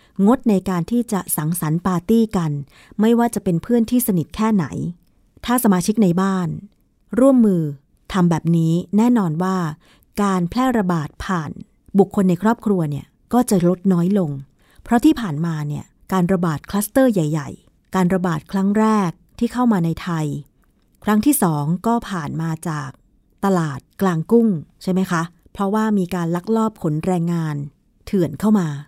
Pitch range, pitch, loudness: 165-215 Hz, 185 Hz, -19 LUFS